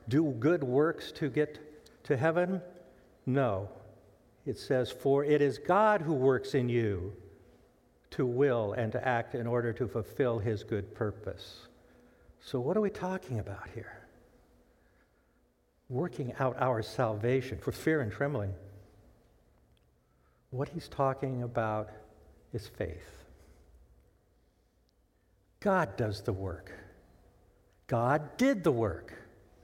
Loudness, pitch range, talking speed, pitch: -32 LUFS, 100-140 Hz, 120 wpm, 120 Hz